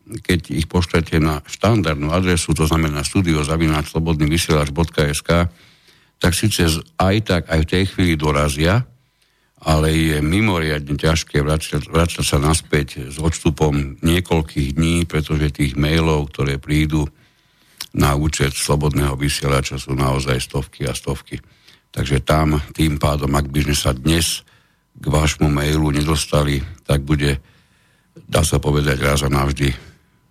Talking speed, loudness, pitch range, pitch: 130 wpm, -18 LUFS, 75-80 Hz, 75 Hz